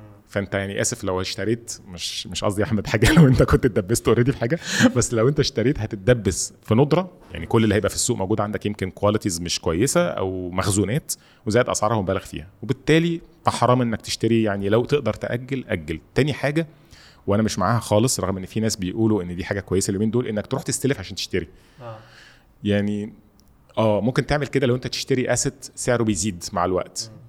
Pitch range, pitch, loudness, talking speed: 100-125 Hz, 110 Hz, -22 LUFS, 190 wpm